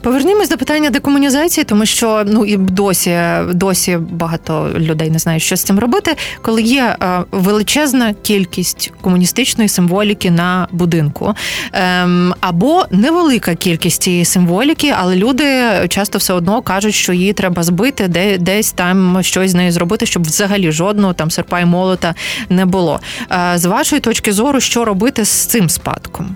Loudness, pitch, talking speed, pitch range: -13 LUFS, 190 Hz, 150 wpm, 180-230 Hz